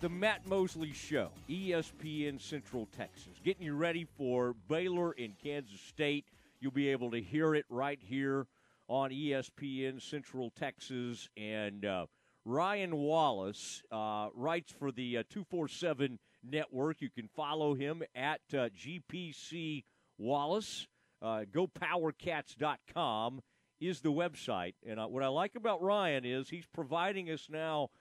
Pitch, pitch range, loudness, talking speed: 145 Hz, 125-165 Hz, -38 LUFS, 135 wpm